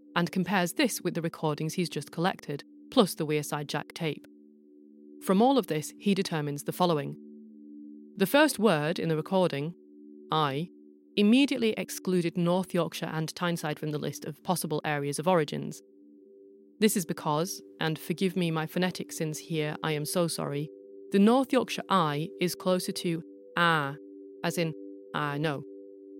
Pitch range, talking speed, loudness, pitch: 130-185 Hz, 160 wpm, -29 LUFS, 160 Hz